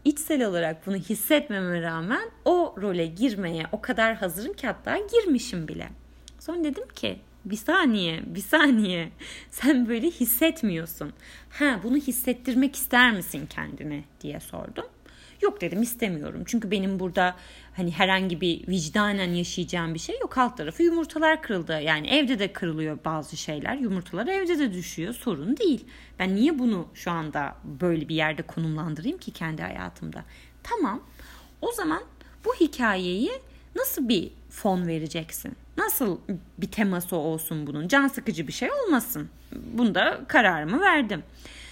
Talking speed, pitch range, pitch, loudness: 140 wpm, 170-275 Hz, 210 Hz, -26 LUFS